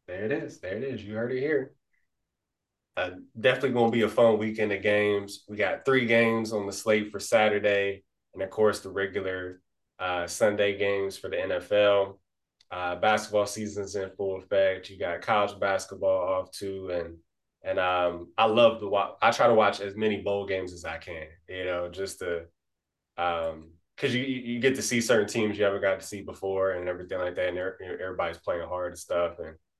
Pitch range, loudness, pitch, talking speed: 90-105 Hz, -27 LUFS, 100 Hz, 200 wpm